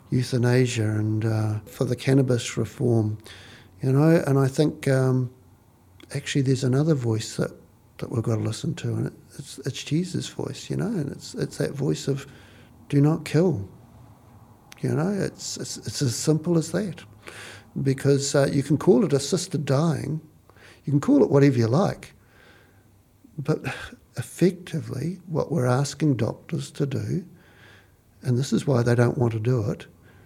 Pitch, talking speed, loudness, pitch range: 130 Hz, 165 wpm, -24 LUFS, 115-145 Hz